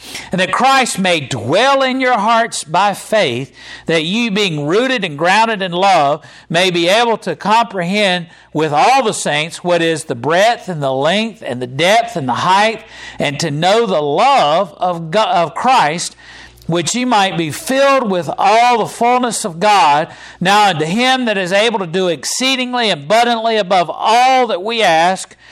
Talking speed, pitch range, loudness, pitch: 175 wpm, 165-230 Hz, -14 LUFS, 200 Hz